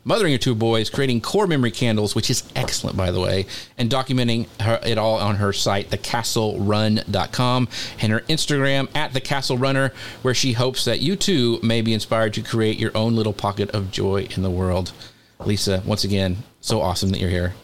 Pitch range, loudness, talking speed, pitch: 100-125 Hz, -21 LUFS, 190 wpm, 115 Hz